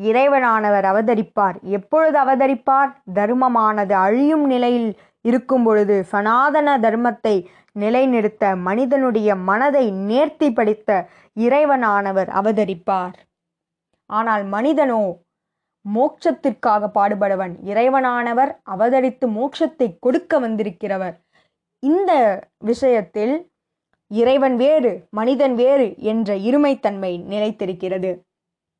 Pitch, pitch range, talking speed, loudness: 225 Hz, 200-270 Hz, 75 wpm, -18 LUFS